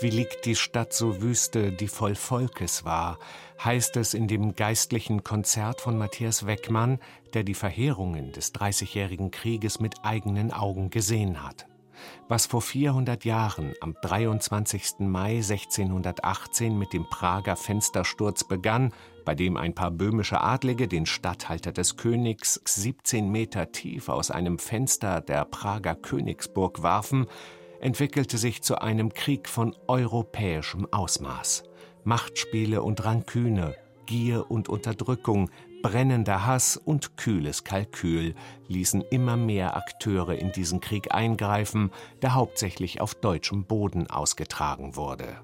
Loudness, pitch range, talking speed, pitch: -27 LUFS, 95-120 Hz, 130 wpm, 110 Hz